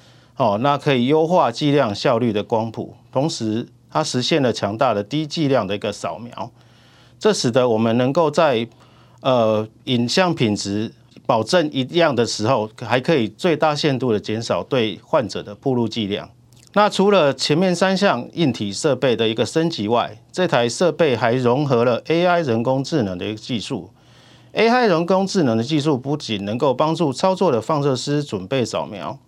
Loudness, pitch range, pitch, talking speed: -19 LUFS, 115-155 Hz, 125 Hz, 265 characters per minute